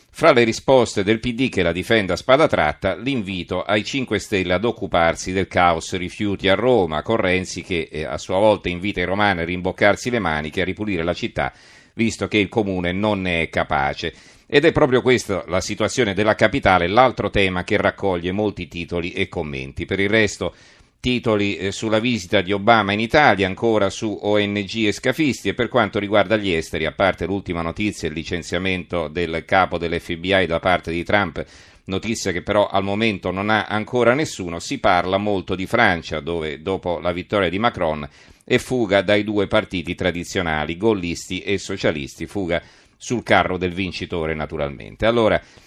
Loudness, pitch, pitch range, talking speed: -20 LUFS, 95 Hz, 90-110 Hz, 175 wpm